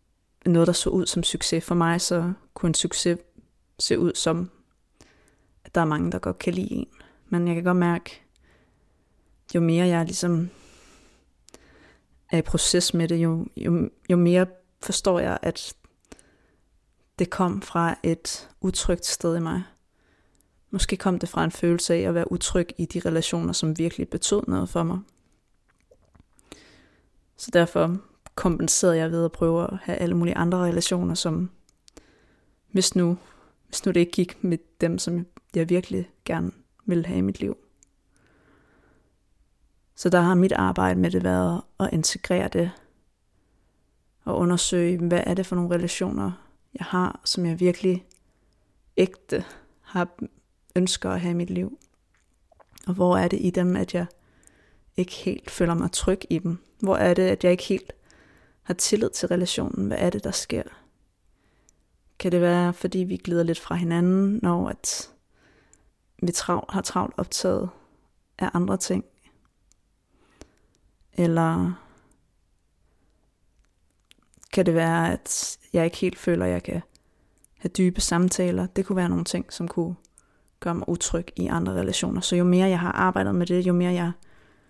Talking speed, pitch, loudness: 160 wpm, 175 Hz, -24 LUFS